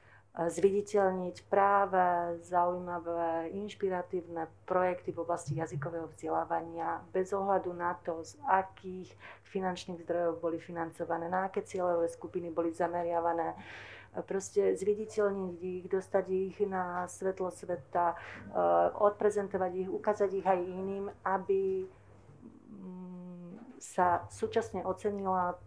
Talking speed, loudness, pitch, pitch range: 100 wpm, -33 LUFS, 180 Hz, 170-195 Hz